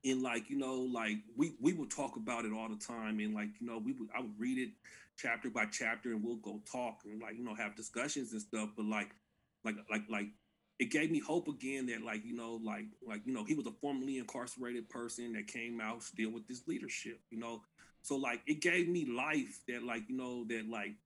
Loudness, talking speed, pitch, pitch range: -40 LUFS, 240 wpm, 115 Hz, 110-130 Hz